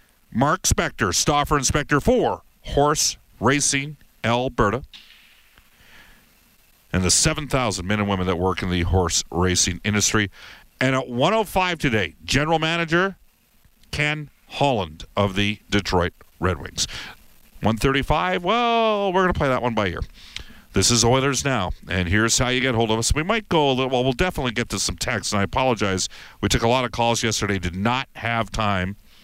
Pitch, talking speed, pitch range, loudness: 120 Hz, 170 wpm, 100-145 Hz, -21 LUFS